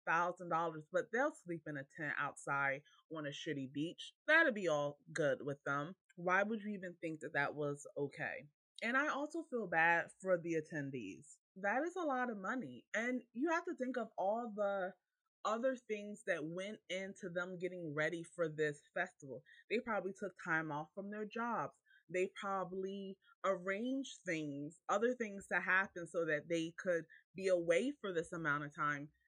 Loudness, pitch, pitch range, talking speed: -40 LUFS, 180 Hz, 160-215 Hz, 180 wpm